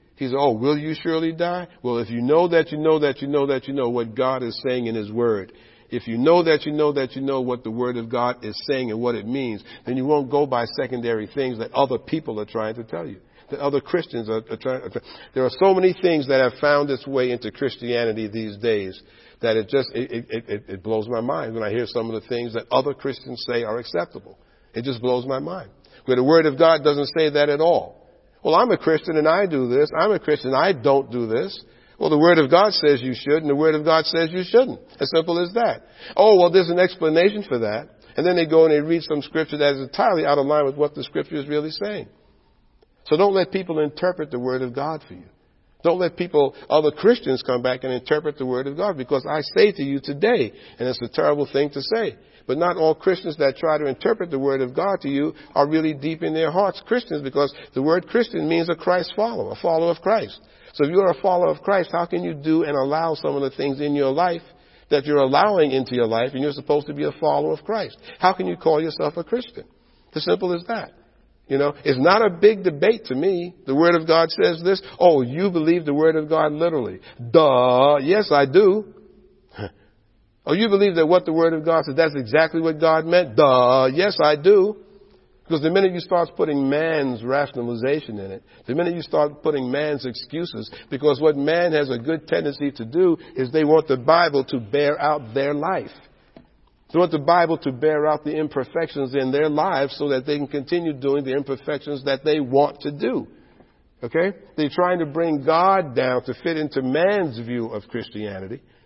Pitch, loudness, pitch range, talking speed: 150 Hz, -21 LUFS, 130-170 Hz, 235 wpm